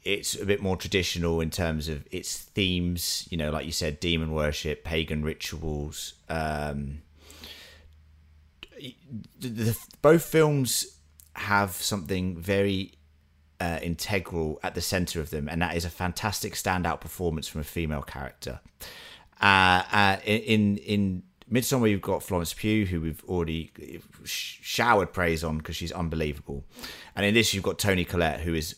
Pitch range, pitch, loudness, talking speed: 80-100 Hz, 85 Hz, -27 LUFS, 150 wpm